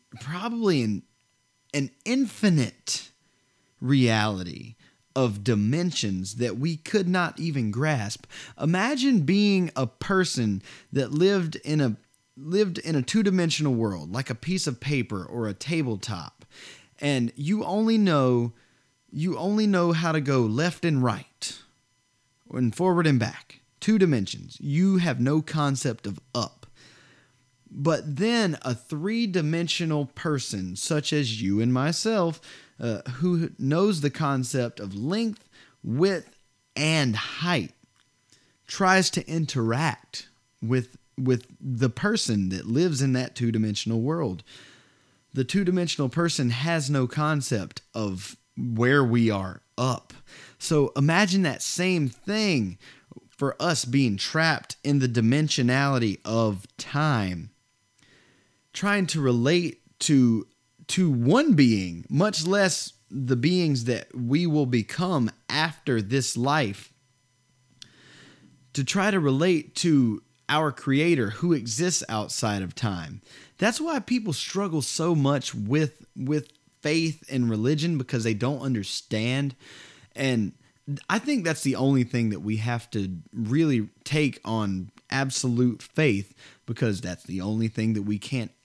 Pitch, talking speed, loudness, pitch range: 135 Hz, 130 wpm, -25 LUFS, 120-165 Hz